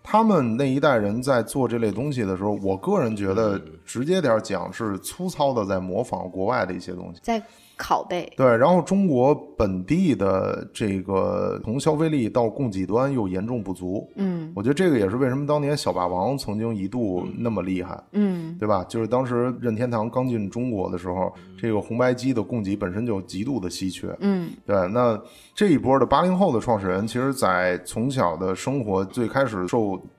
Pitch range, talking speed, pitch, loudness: 95-135 Hz, 290 characters per minute, 115 Hz, -24 LUFS